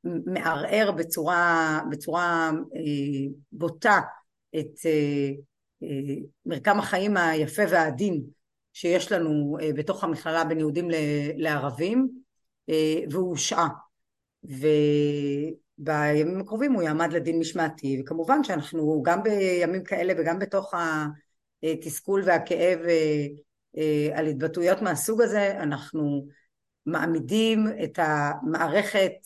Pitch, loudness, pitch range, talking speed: 160 Hz, -26 LUFS, 150-180 Hz, 85 wpm